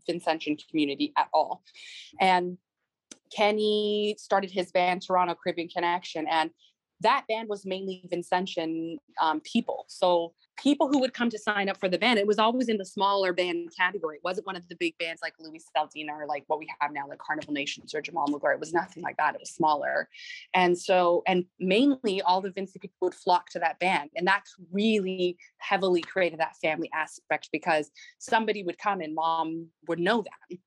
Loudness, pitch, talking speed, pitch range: -28 LUFS, 180 Hz, 195 wpm, 165-195 Hz